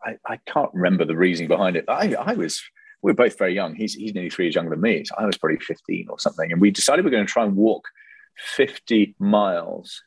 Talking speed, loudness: 250 wpm, -21 LUFS